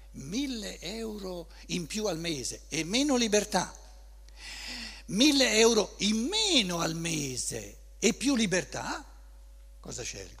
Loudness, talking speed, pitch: -28 LUFS, 115 wpm, 175 Hz